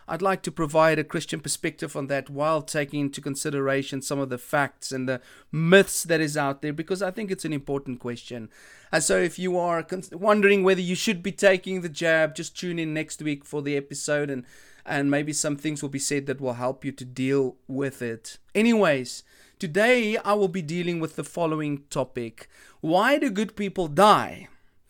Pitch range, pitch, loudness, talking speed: 140-185 Hz, 155 Hz, -25 LUFS, 200 wpm